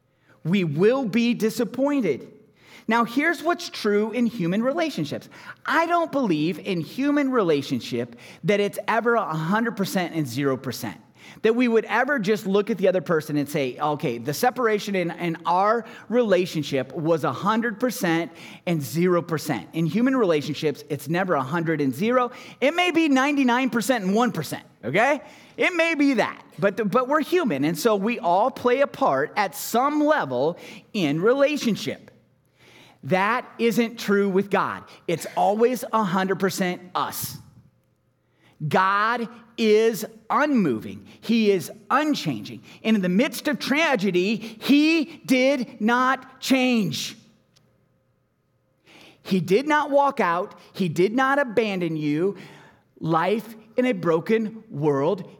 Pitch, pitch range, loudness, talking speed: 215 Hz, 170-250 Hz, -23 LUFS, 130 wpm